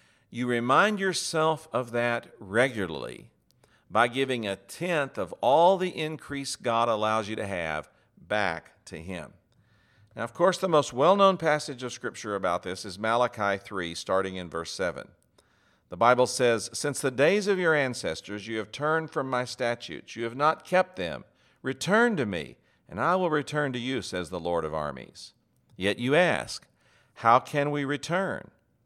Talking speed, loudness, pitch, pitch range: 170 wpm, -27 LUFS, 125 Hz, 105-150 Hz